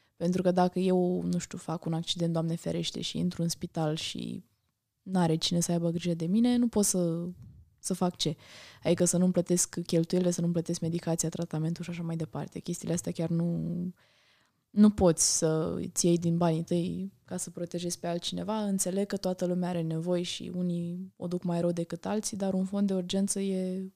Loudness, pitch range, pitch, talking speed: -30 LUFS, 165-185 Hz, 175 Hz, 205 wpm